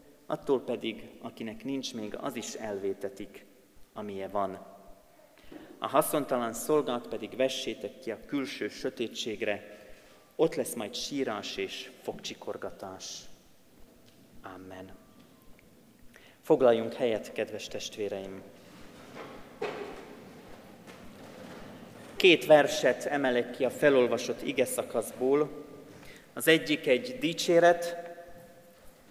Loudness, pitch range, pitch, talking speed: -30 LUFS, 105-155 Hz, 130 Hz, 85 wpm